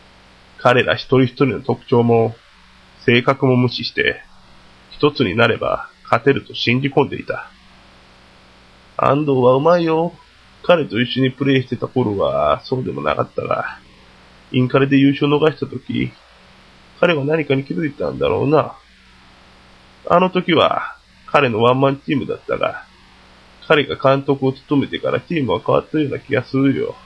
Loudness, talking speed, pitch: -17 LUFS, 290 characters per minute, 130 Hz